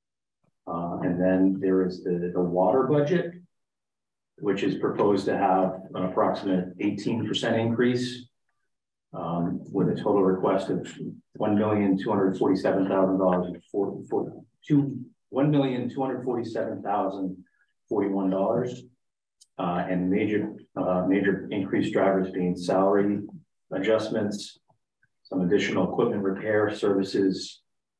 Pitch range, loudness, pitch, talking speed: 95-115 Hz, -26 LUFS, 100 Hz, 90 wpm